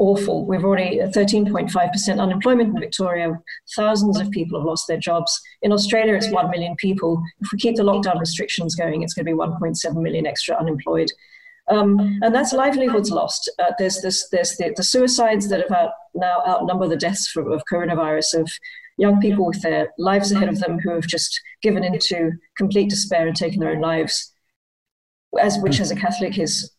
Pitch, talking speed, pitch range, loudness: 185 Hz, 190 wpm, 170-210 Hz, -20 LUFS